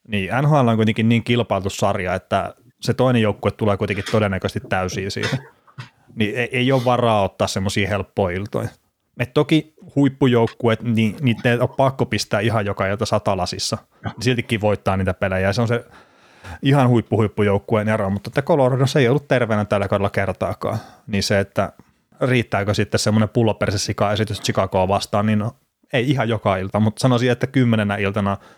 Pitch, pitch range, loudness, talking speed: 110 Hz, 100-120 Hz, -20 LUFS, 170 wpm